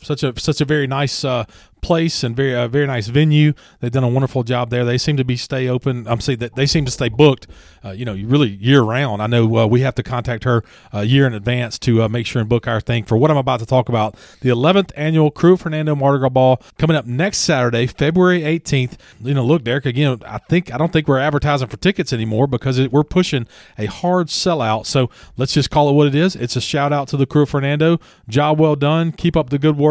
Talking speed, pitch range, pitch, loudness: 255 wpm, 120-150 Hz, 135 Hz, -17 LUFS